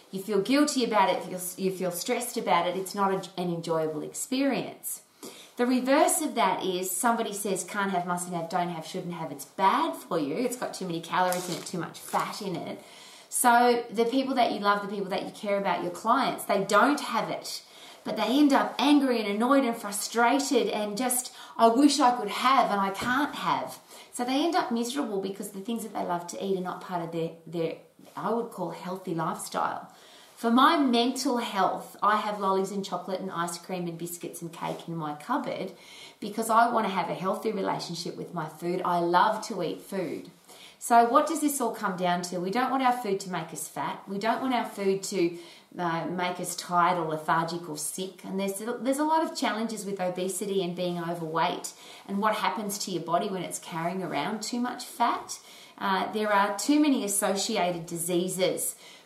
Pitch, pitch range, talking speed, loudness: 200 Hz, 180-240 Hz, 210 wpm, -28 LUFS